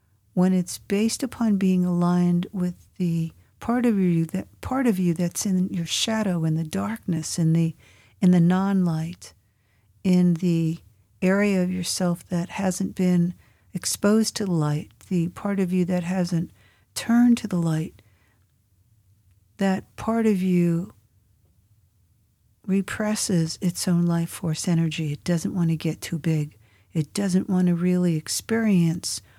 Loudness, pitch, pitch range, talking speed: -24 LUFS, 175 Hz, 155-190 Hz, 145 wpm